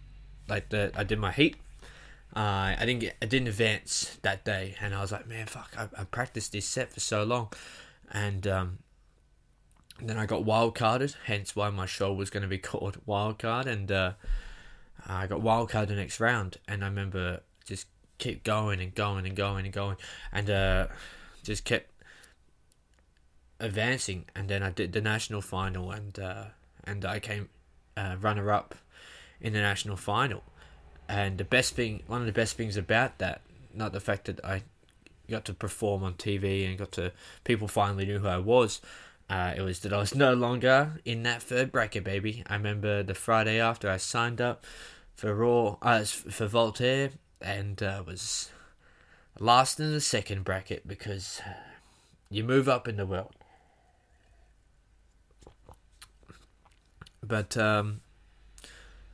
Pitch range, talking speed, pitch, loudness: 95-115 Hz, 165 wpm, 100 Hz, -30 LUFS